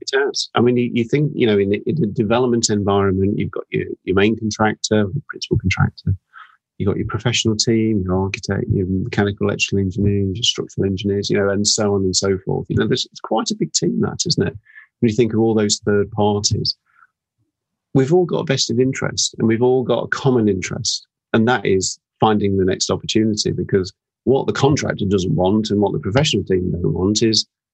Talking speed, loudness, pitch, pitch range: 210 wpm, -18 LUFS, 105 Hz, 100-120 Hz